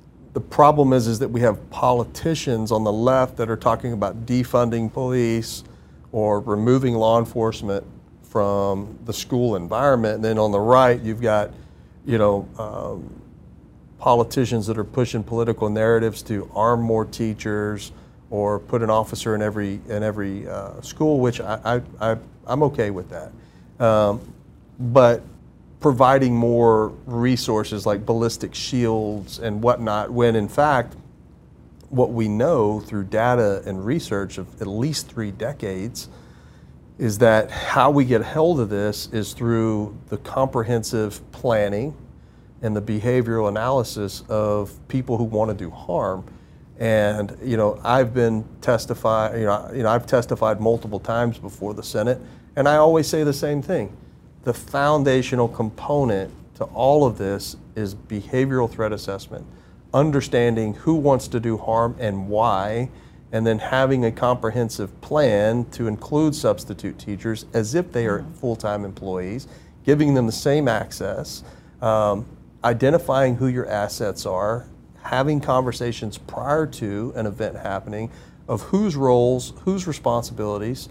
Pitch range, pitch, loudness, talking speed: 105-125 Hz, 115 Hz, -21 LUFS, 145 wpm